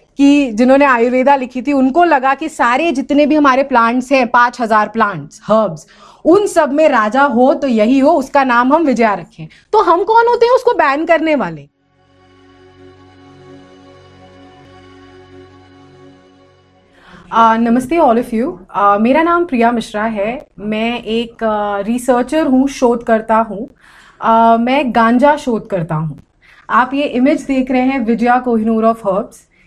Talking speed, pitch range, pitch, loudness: 150 wpm, 195-275 Hz, 235 Hz, -13 LUFS